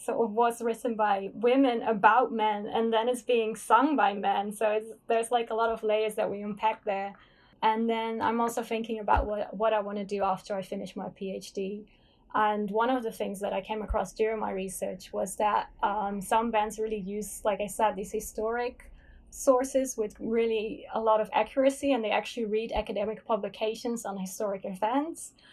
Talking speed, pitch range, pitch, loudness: 195 wpm, 205-230 Hz, 220 Hz, -29 LUFS